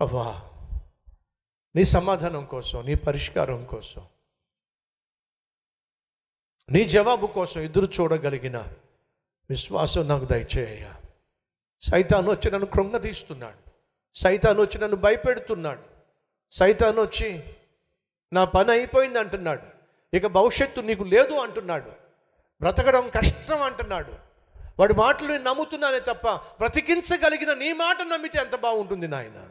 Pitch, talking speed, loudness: 195 Hz, 100 wpm, -23 LUFS